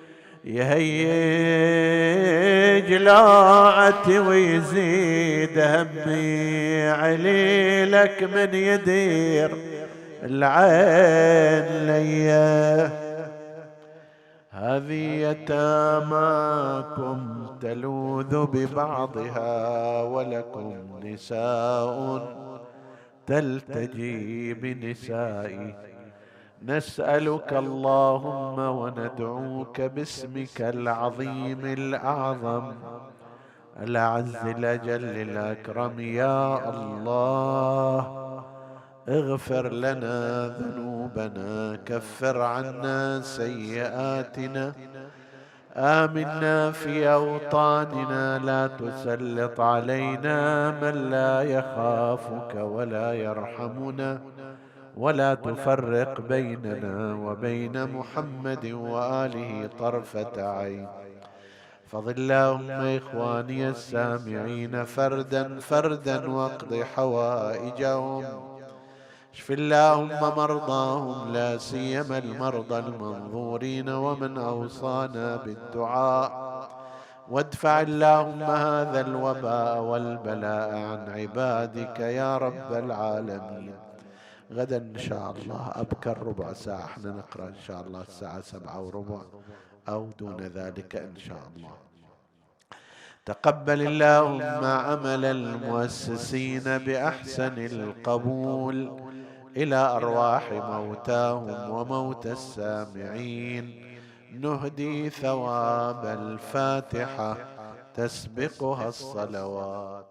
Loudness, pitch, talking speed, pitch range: -24 LUFS, 130 Hz, 65 wpm, 115-140 Hz